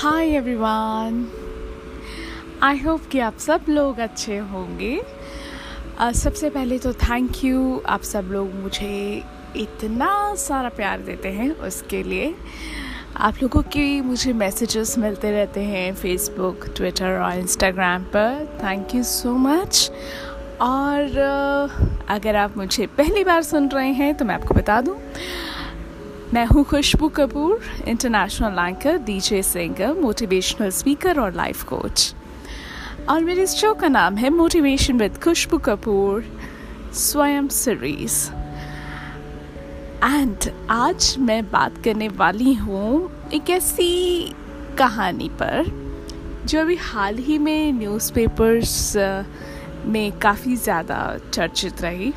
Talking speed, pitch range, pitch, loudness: 120 wpm, 200-285 Hz, 235 Hz, -21 LUFS